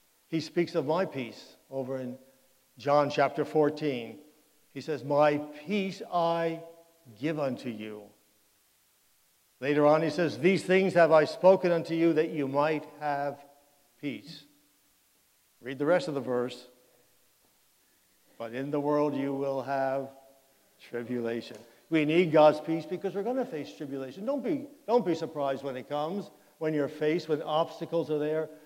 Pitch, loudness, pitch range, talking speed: 150 Hz, -29 LUFS, 135-165 Hz, 155 wpm